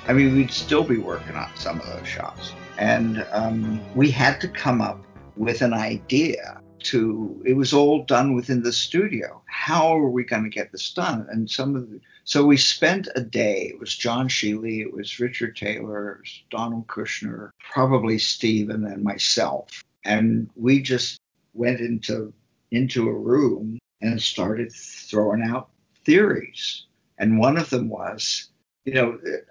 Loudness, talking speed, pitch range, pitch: -22 LUFS, 165 wpm, 110-130 Hz, 115 Hz